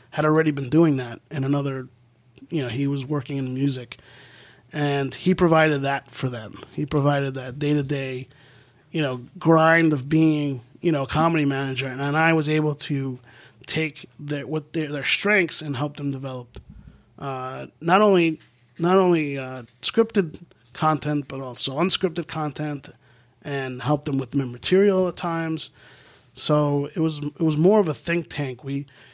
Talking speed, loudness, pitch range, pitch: 170 wpm, -22 LUFS, 130-160 Hz, 145 Hz